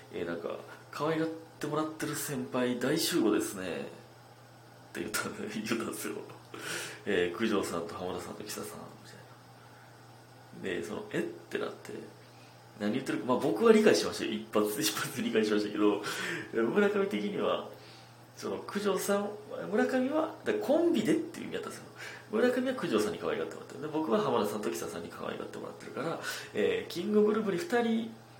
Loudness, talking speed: -32 LUFS, 365 characters per minute